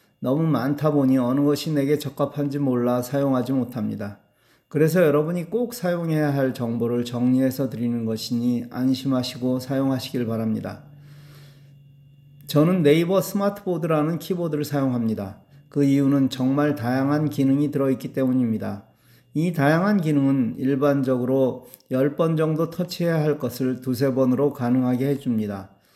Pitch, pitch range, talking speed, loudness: 140 Hz, 125-150 Hz, 330 characters per minute, -22 LUFS